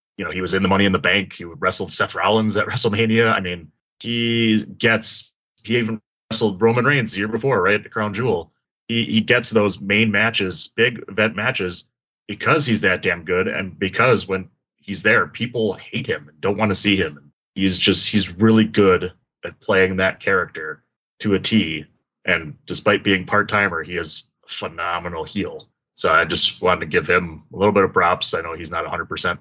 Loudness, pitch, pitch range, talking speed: -19 LUFS, 105 Hz, 95-115 Hz, 200 wpm